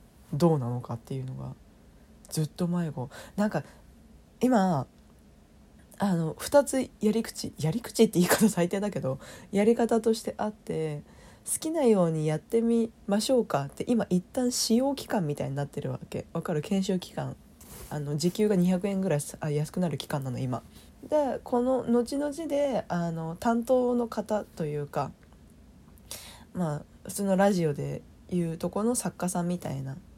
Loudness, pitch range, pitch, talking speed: -28 LUFS, 150-230 Hz, 180 Hz, 295 characters per minute